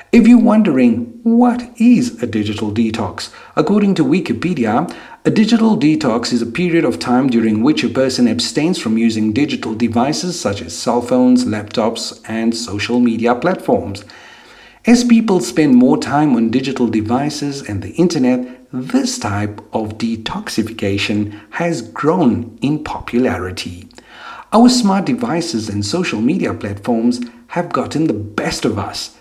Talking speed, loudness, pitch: 140 wpm, -15 LUFS, 130 Hz